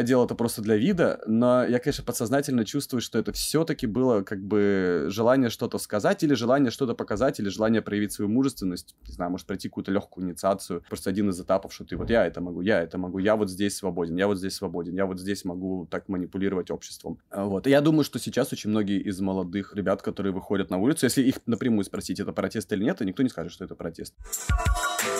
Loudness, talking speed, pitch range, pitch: -26 LUFS, 220 wpm, 95-120 Hz, 100 Hz